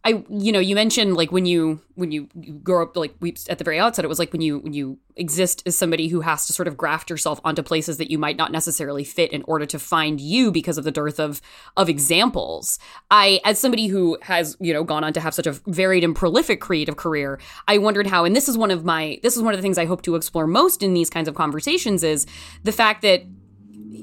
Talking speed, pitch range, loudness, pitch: 255 wpm, 155-190 Hz, -20 LUFS, 170 Hz